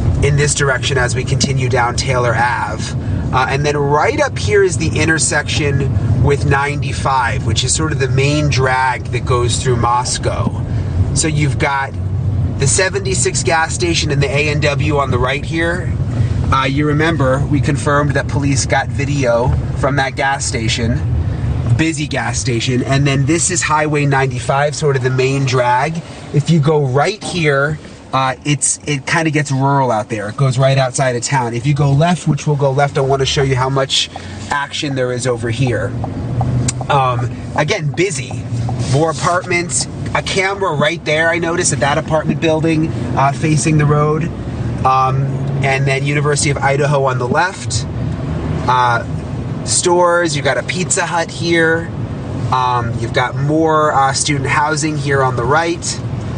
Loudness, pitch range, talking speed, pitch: -15 LUFS, 125-150 Hz, 170 wpm, 135 Hz